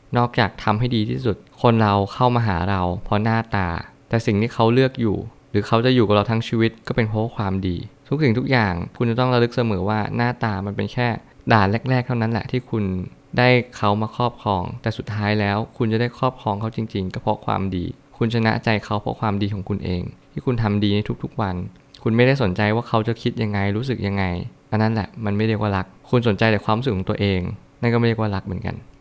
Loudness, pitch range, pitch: -21 LUFS, 100-120 Hz, 110 Hz